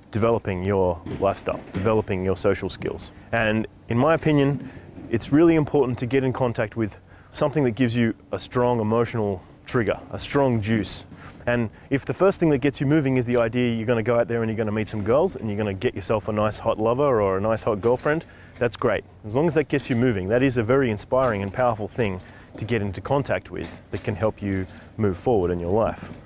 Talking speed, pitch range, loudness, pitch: 230 wpm, 100-130 Hz, -23 LUFS, 115 Hz